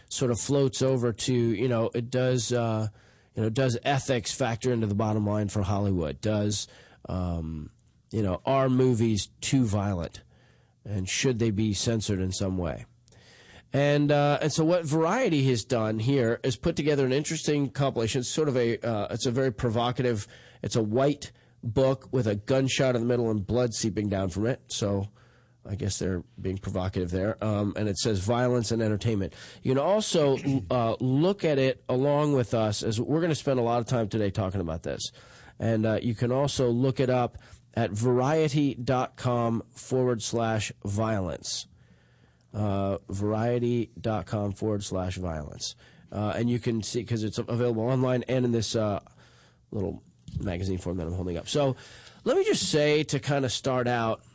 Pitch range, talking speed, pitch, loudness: 105-130 Hz, 180 wpm, 120 Hz, -27 LUFS